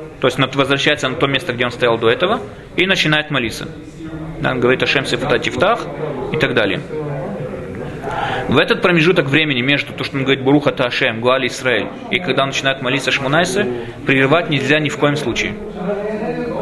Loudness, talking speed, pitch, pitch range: -16 LUFS, 175 wpm, 140 Hz, 130-155 Hz